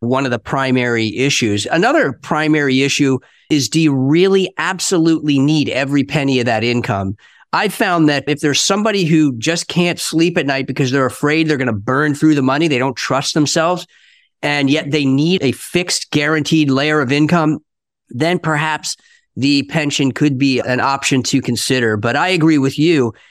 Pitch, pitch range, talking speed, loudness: 145 Hz, 130-160 Hz, 180 wpm, -15 LUFS